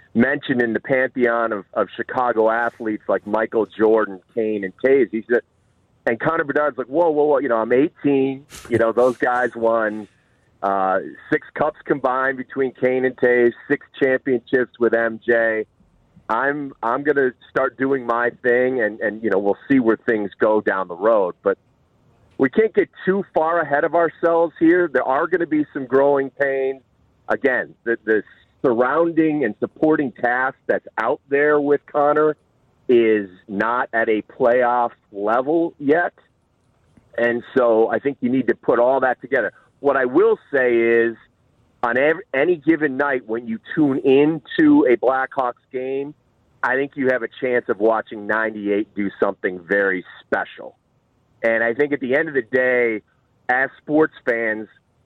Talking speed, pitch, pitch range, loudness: 165 wpm, 125 Hz, 110-145 Hz, -20 LUFS